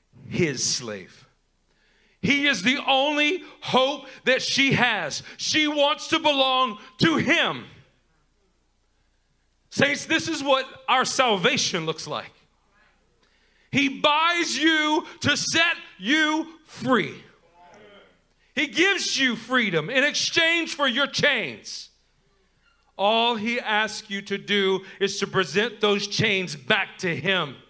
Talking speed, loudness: 115 wpm, -22 LUFS